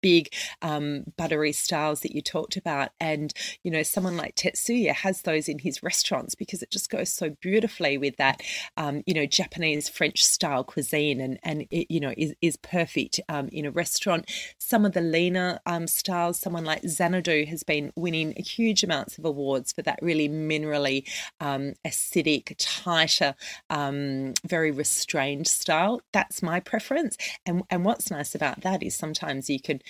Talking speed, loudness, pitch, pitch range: 175 wpm, -26 LUFS, 160 Hz, 150-180 Hz